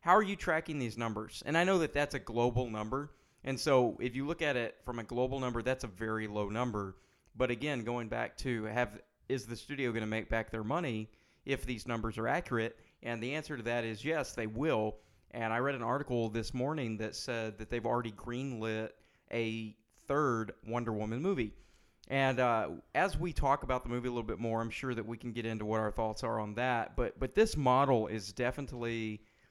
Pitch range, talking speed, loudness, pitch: 110-130 Hz, 220 wpm, -35 LUFS, 120 Hz